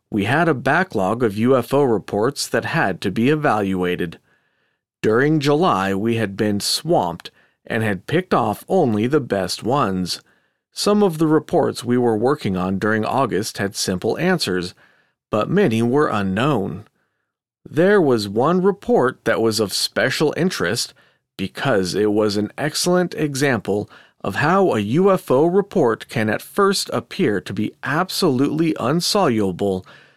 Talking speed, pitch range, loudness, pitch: 140 wpm, 100-155 Hz, -19 LUFS, 115 Hz